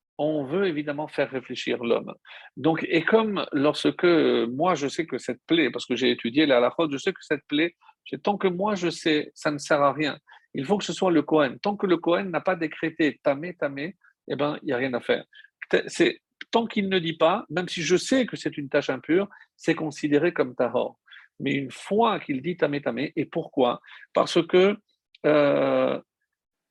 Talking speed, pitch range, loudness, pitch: 210 wpm, 145-195 Hz, -25 LUFS, 165 Hz